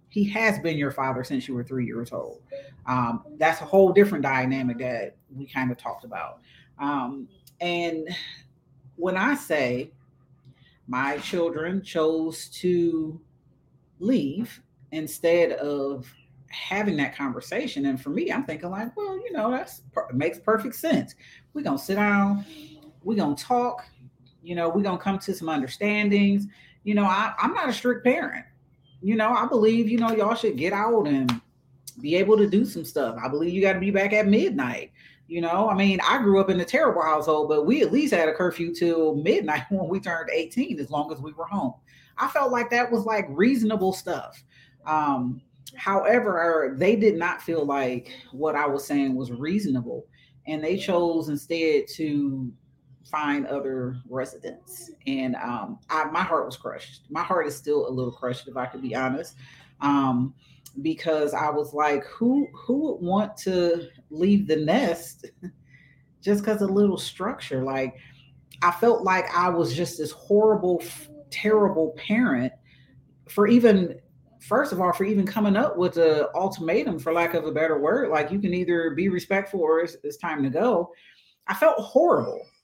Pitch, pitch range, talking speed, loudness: 165 Hz, 140-200 Hz, 175 wpm, -24 LUFS